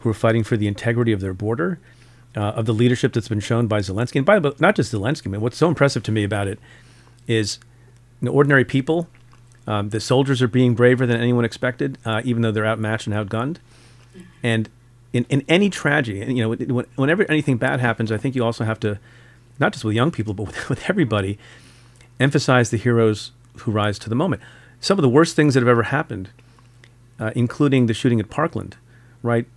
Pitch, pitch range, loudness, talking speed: 120 Hz, 115-130 Hz, -20 LUFS, 215 wpm